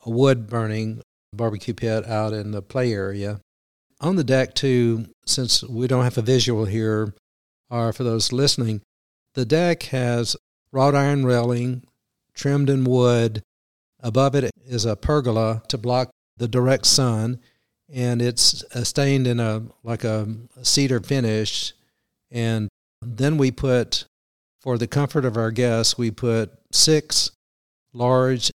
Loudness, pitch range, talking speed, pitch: -21 LUFS, 110-130 Hz, 140 wpm, 120 Hz